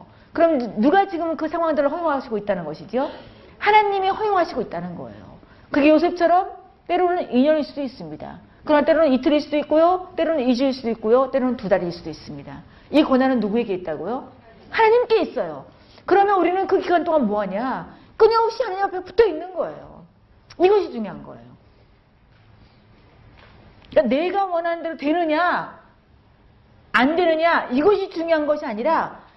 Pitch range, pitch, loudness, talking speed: 210-350 Hz, 300 Hz, -20 LUFS, 365 characters per minute